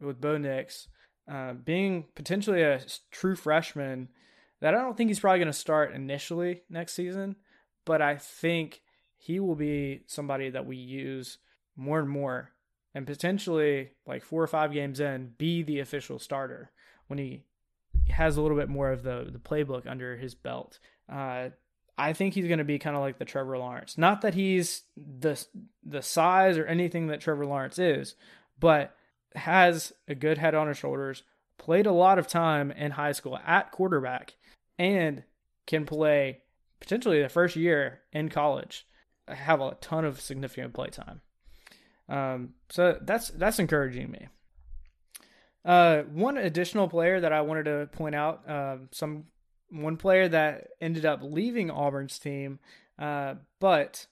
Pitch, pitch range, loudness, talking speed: 150 Hz, 140-170 Hz, -28 LUFS, 165 wpm